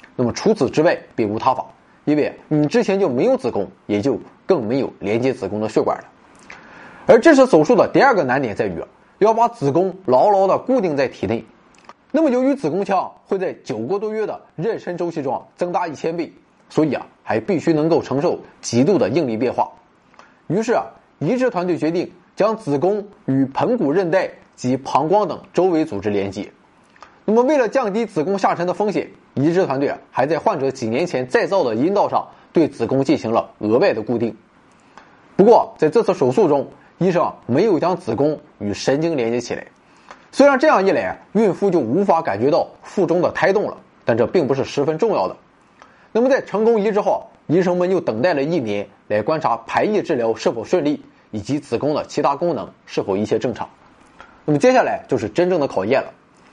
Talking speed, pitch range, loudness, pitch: 290 characters per minute, 135-215 Hz, -19 LUFS, 175 Hz